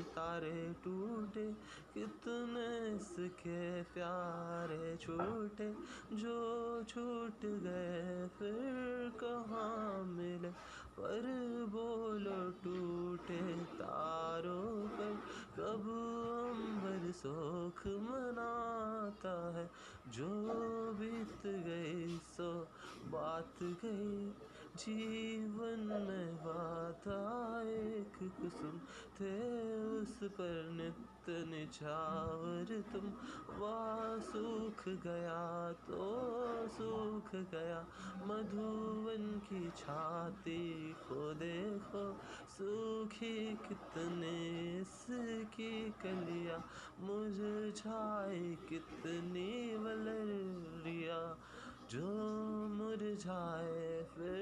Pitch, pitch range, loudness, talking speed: 200 Hz, 170-220 Hz, -44 LUFS, 60 wpm